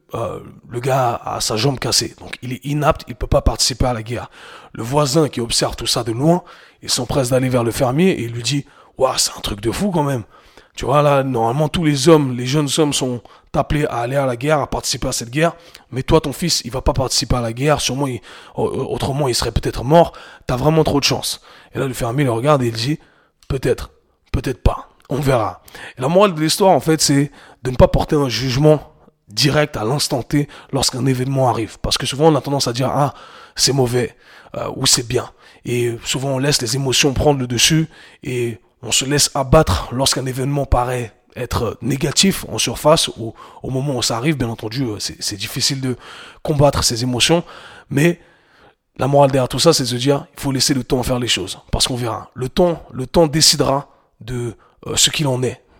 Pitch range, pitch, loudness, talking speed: 120-150 Hz, 135 Hz, -17 LUFS, 225 wpm